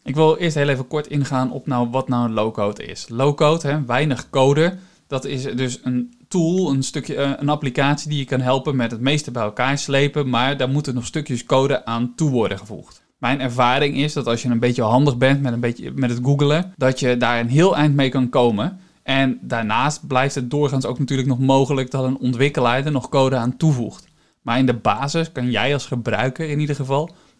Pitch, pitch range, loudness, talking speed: 135 Hz, 125-145 Hz, -19 LUFS, 220 wpm